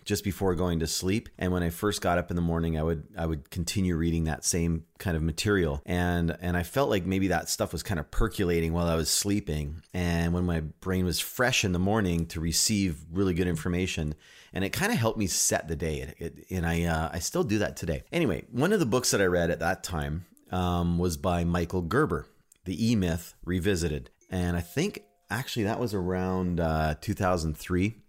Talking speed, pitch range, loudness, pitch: 220 wpm, 80-95 Hz, -28 LUFS, 85 Hz